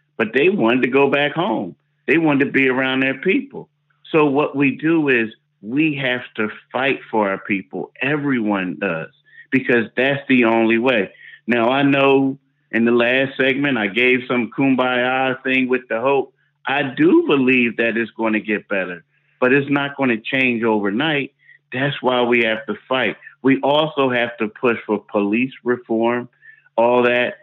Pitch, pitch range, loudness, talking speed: 130 Hz, 115-140 Hz, -18 LUFS, 175 wpm